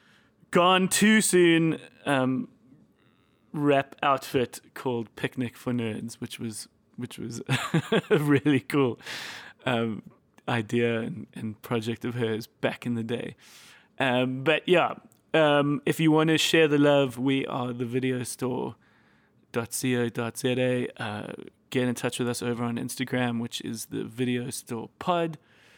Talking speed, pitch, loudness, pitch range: 135 wpm, 125 Hz, -26 LUFS, 120-150 Hz